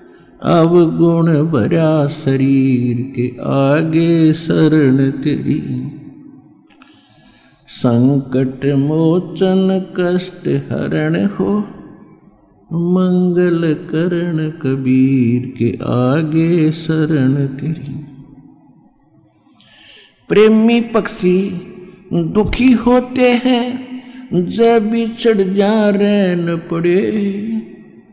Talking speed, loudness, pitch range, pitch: 65 wpm, -14 LUFS, 140-200 Hz, 170 Hz